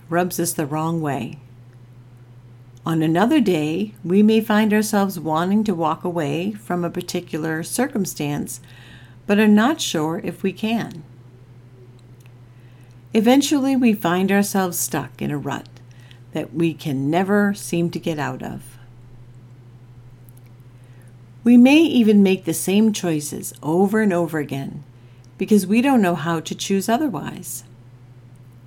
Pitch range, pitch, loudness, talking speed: 125-195 Hz, 160 Hz, -19 LUFS, 130 wpm